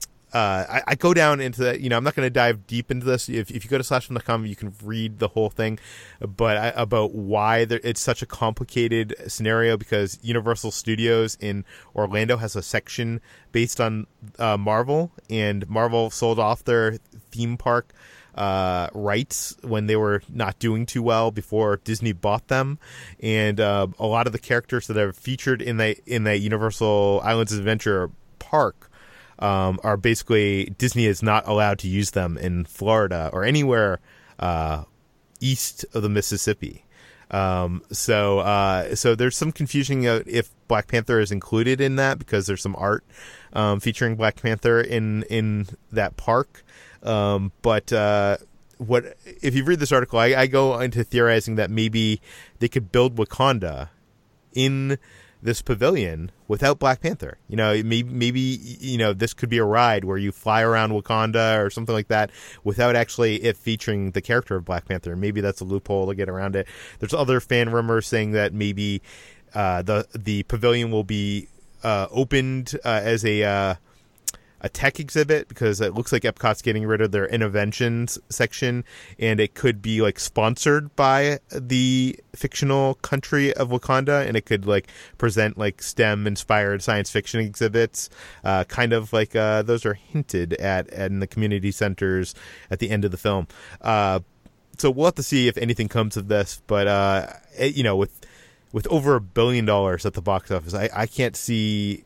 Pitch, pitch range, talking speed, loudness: 110 Hz, 100-120 Hz, 180 wpm, -23 LUFS